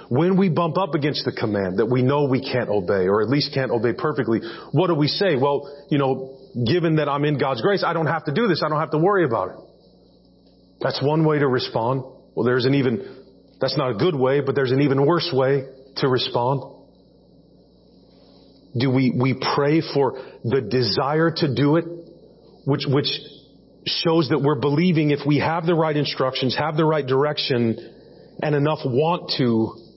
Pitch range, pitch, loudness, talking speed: 130-155 Hz, 140 Hz, -21 LUFS, 195 wpm